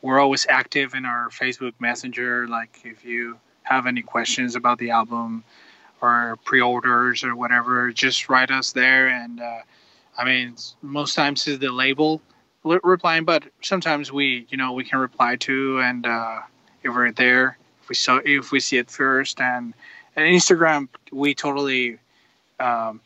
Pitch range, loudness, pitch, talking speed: 120-135 Hz, -20 LUFS, 130 Hz, 160 wpm